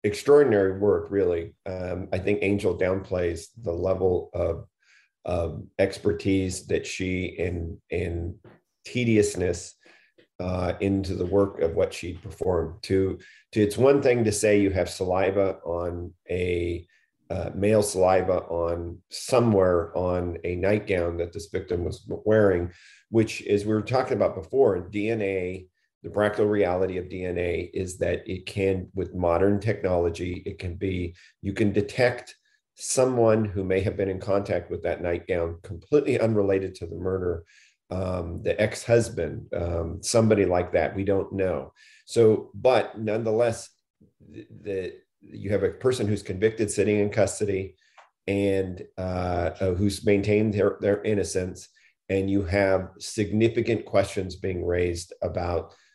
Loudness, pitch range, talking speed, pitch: -25 LUFS, 90-105 Hz, 140 wpm, 95 Hz